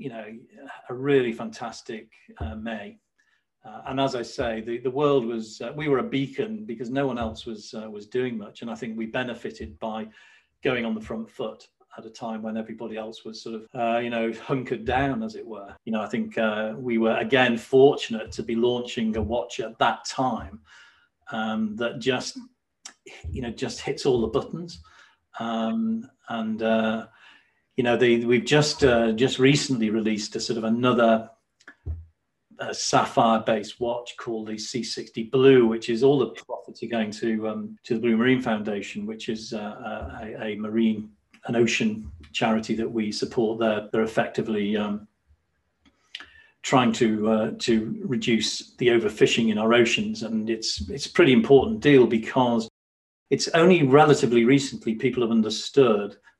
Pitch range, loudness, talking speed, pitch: 110-125 Hz, -24 LUFS, 175 wpm, 115 Hz